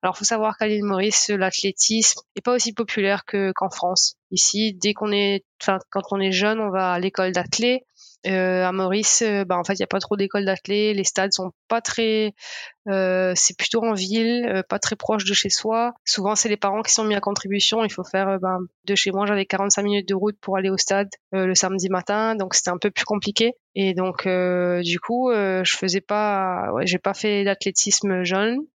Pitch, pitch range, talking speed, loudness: 200 Hz, 190-215 Hz, 225 wpm, -21 LUFS